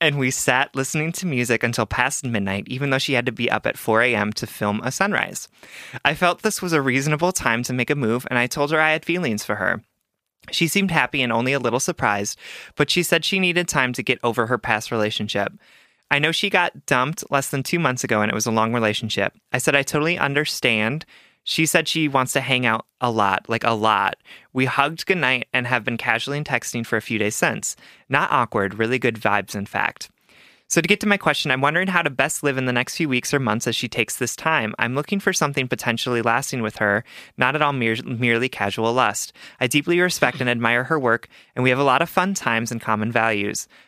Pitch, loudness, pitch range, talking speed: 125 Hz, -21 LUFS, 115-150 Hz, 235 wpm